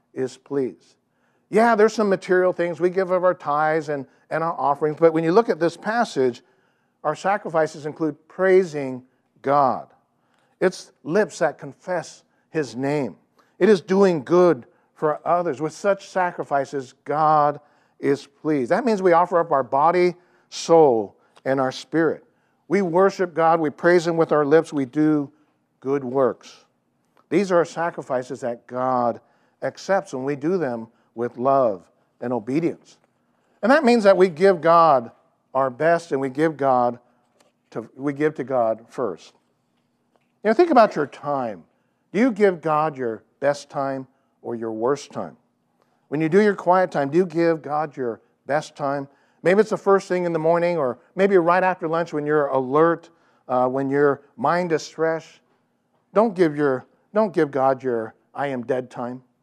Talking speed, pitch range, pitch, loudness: 170 wpm, 135-180 Hz, 155 Hz, -21 LUFS